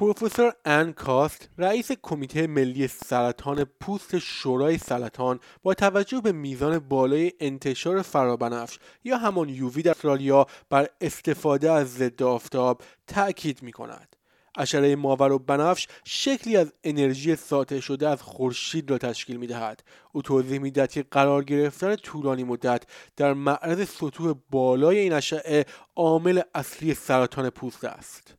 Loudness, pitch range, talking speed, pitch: -25 LUFS, 130-165 Hz, 130 wpm, 140 Hz